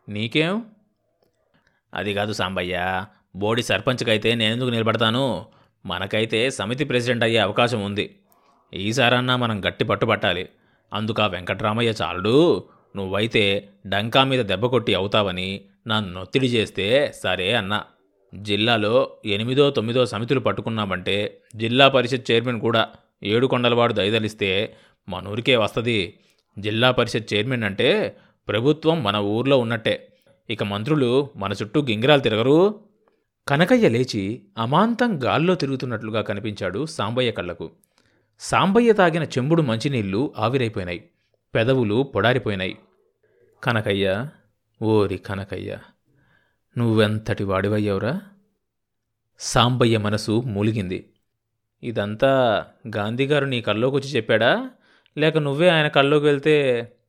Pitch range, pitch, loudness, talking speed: 105-135 Hz, 115 Hz, -21 LUFS, 100 wpm